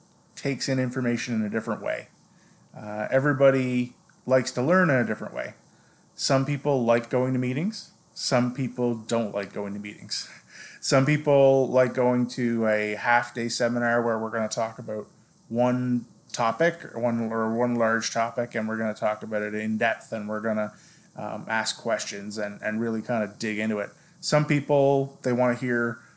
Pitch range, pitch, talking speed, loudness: 110-130 Hz, 120 Hz, 185 wpm, -26 LUFS